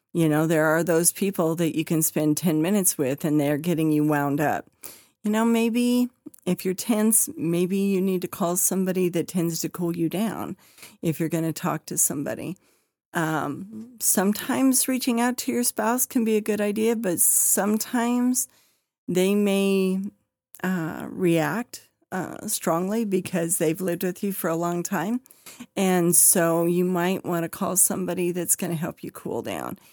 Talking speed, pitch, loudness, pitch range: 175 wpm, 185 Hz, -23 LUFS, 165-215 Hz